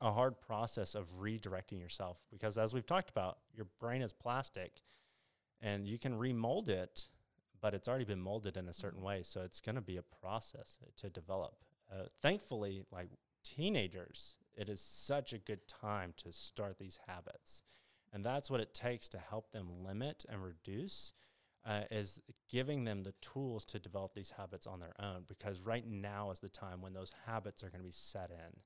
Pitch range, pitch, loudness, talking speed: 95-115 Hz, 105 Hz, -44 LUFS, 195 wpm